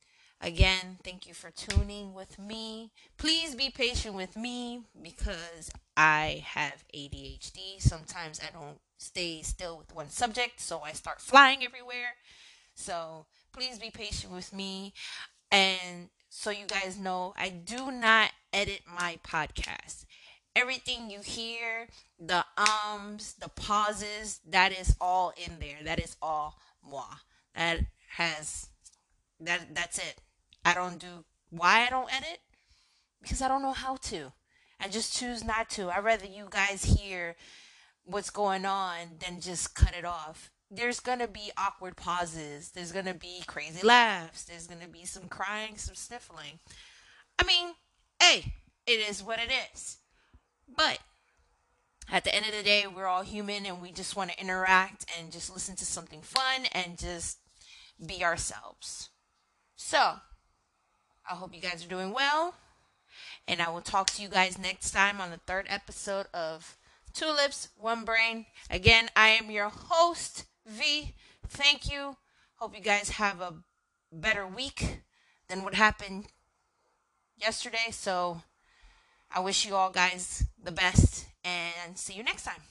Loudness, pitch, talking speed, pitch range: -29 LUFS, 195 Hz, 150 wpm, 175-230 Hz